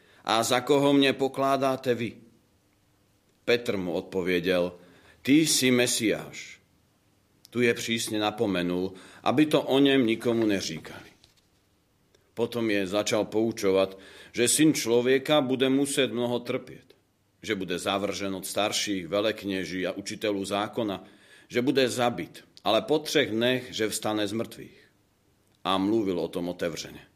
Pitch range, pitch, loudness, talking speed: 100-125 Hz, 110 Hz, -26 LUFS, 130 wpm